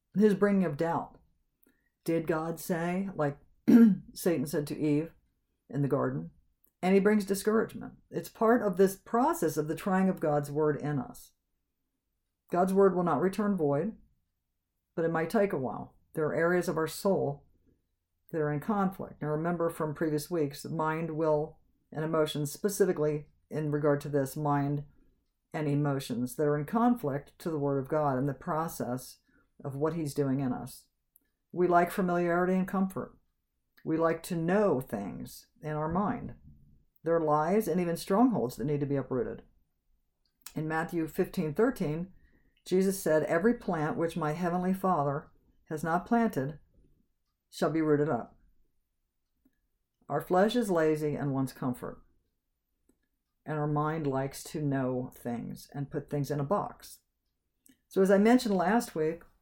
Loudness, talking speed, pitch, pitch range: -30 LUFS, 160 wpm, 160 Hz, 145-185 Hz